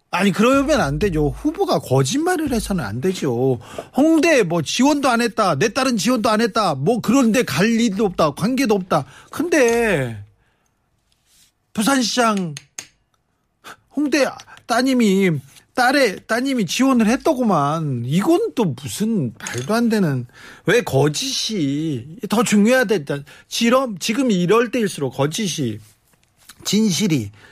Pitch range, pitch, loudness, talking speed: 150-245 Hz, 215 Hz, -18 LUFS, 240 characters per minute